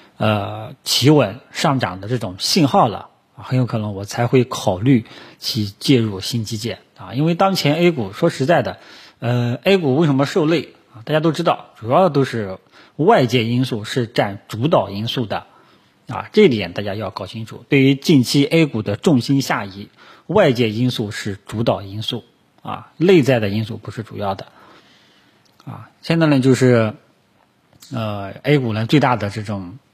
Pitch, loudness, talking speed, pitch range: 125 Hz, -18 LUFS, 245 characters per minute, 110-140 Hz